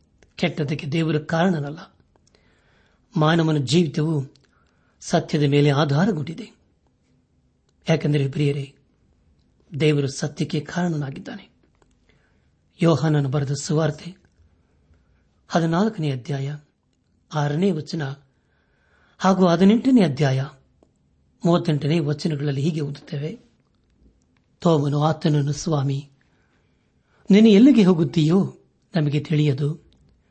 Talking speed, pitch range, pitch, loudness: 65 wpm, 135-165 Hz, 150 Hz, -21 LUFS